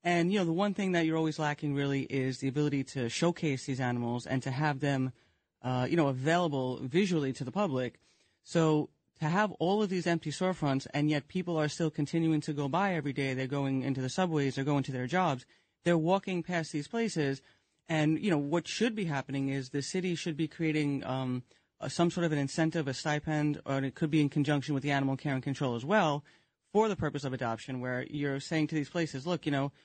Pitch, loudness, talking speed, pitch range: 150 Hz, -32 LUFS, 230 wpm, 135-170 Hz